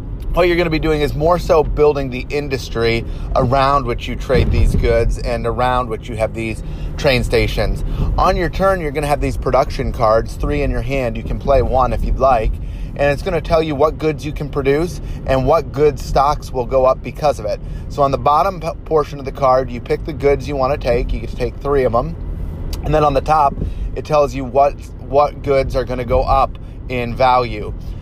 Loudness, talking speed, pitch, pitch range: -17 LUFS, 230 wpm, 130 Hz, 115-145 Hz